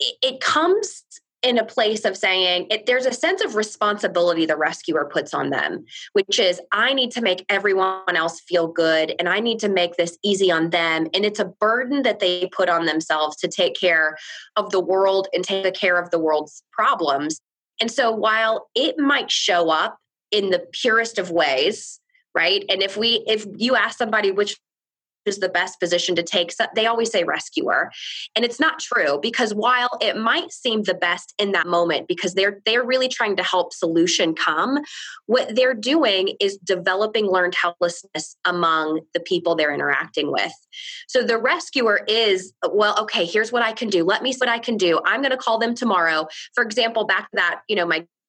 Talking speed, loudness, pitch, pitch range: 200 wpm, -20 LUFS, 205 Hz, 175-245 Hz